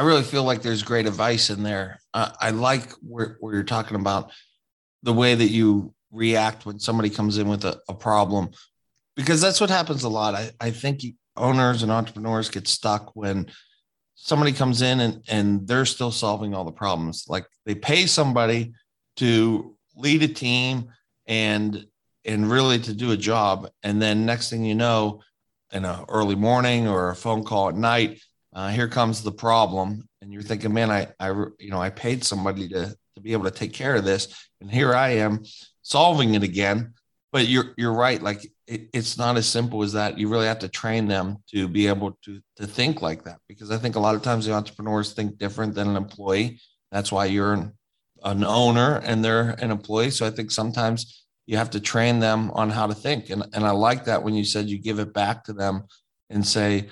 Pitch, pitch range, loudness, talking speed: 110 Hz, 105-120 Hz, -23 LUFS, 210 wpm